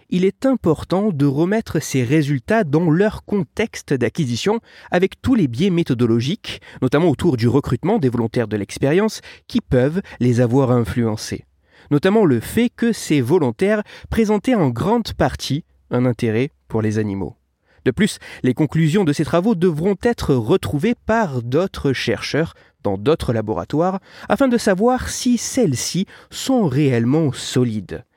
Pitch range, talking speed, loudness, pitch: 125-210 Hz, 145 wpm, -19 LUFS, 160 Hz